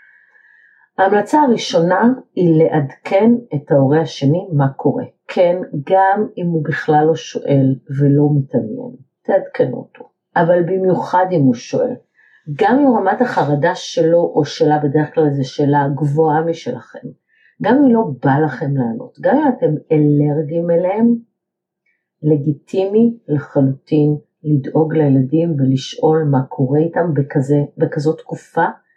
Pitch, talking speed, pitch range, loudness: 160 Hz, 125 wpm, 145-190 Hz, -16 LUFS